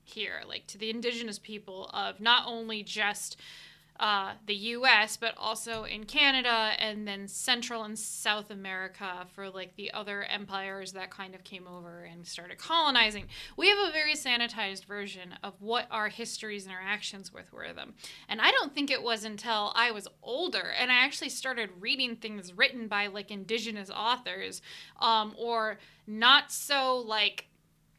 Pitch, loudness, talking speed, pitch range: 215 Hz, -29 LUFS, 165 wpm, 200-235 Hz